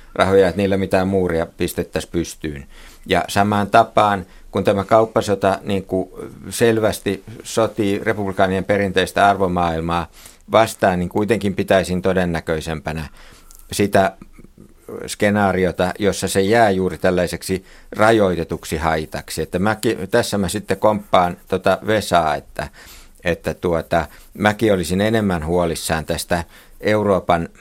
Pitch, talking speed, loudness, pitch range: 95 Hz, 110 wpm, -19 LUFS, 85-100 Hz